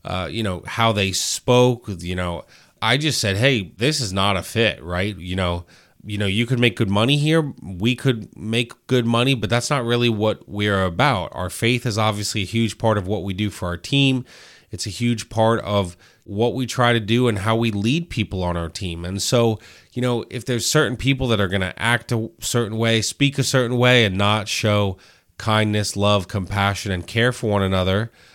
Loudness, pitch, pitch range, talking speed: -20 LUFS, 110 Hz, 100-120 Hz, 220 wpm